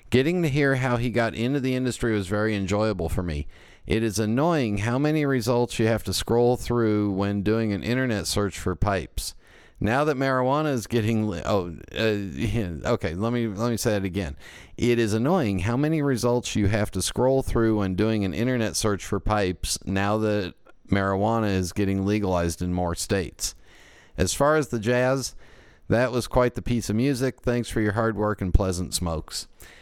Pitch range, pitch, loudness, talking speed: 95-120 Hz, 110 Hz, -25 LUFS, 195 wpm